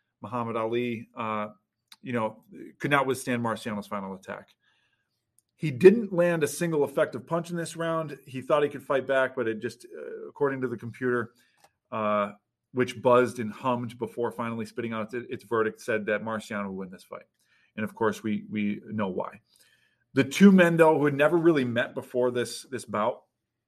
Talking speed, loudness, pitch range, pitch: 190 wpm, -27 LUFS, 110-145 Hz, 125 Hz